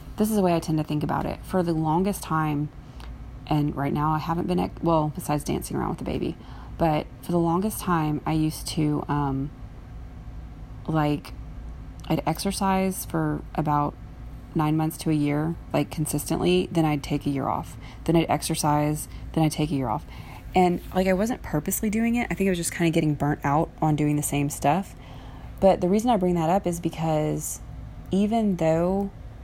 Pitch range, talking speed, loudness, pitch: 145-175 Hz, 200 wpm, -25 LUFS, 155 Hz